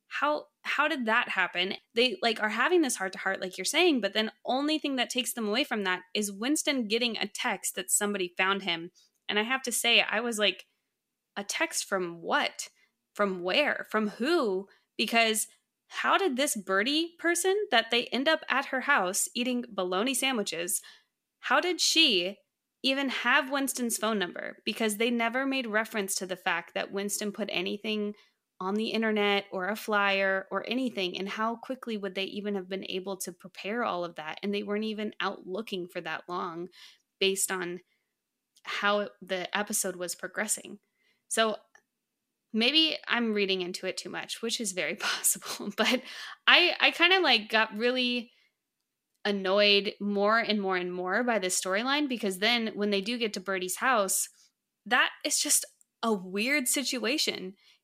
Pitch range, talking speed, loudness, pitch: 195-250 Hz, 175 wpm, -28 LUFS, 215 Hz